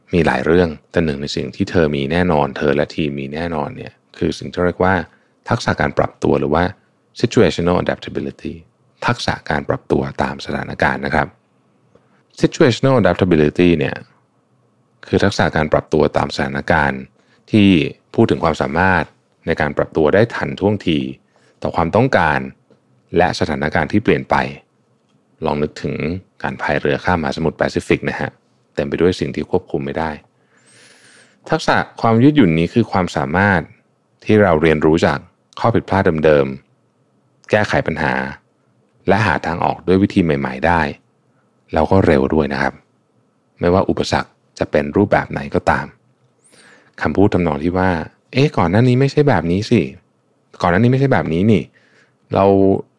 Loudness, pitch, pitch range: -17 LUFS, 85 Hz, 70-95 Hz